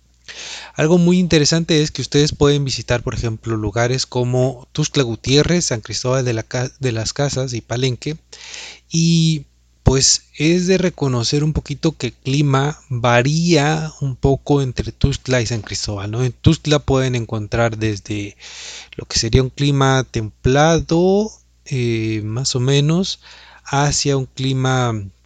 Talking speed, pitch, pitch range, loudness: 145 wpm, 130 Hz, 115-150 Hz, -18 LUFS